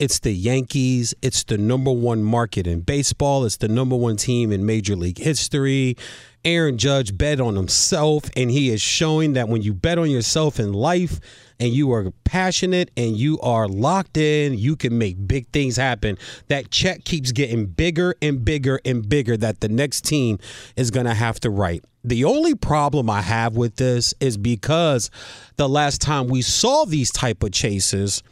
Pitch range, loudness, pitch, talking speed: 110-145 Hz, -20 LUFS, 125 Hz, 185 wpm